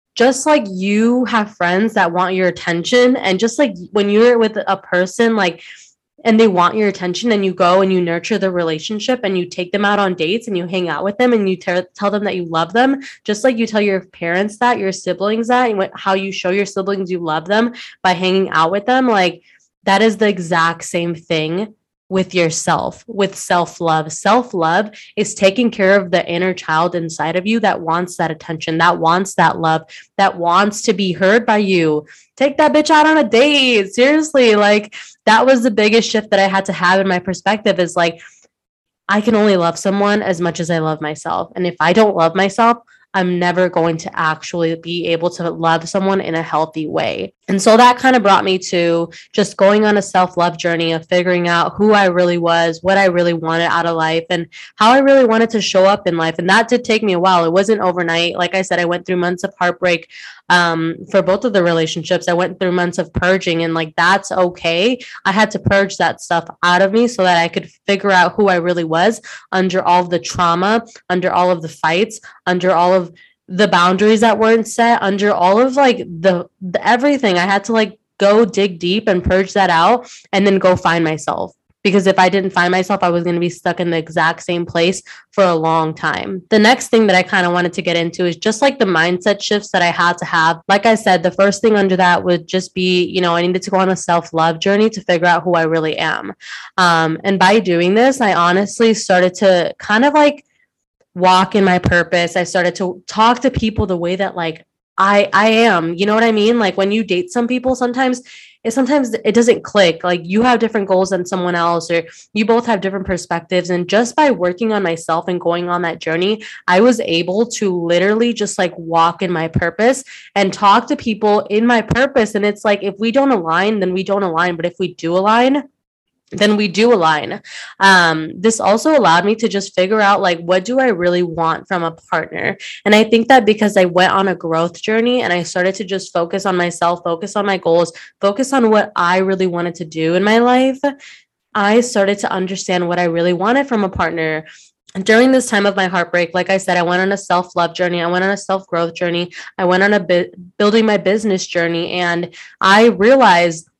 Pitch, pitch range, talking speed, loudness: 190 Hz, 175-215 Hz, 230 wpm, -14 LUFS